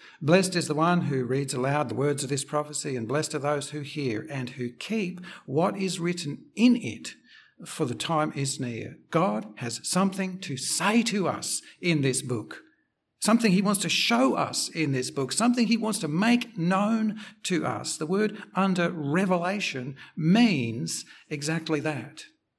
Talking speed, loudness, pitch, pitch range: 175 wpm, -27 LUFS, 160 Hz, 140-195 Hz